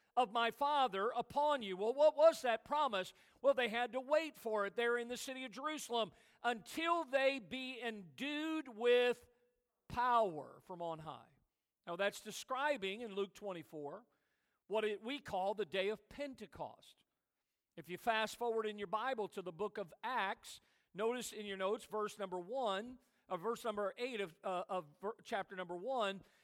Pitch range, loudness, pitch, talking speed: 195-255 Hz, -39 LUFS, 225 Hz, 170 wpm